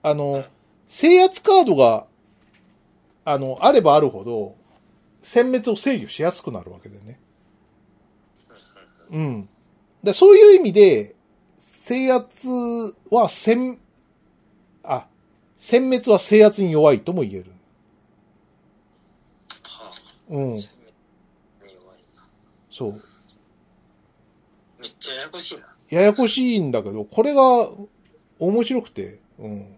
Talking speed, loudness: 185 characters per minute, -17 LUFS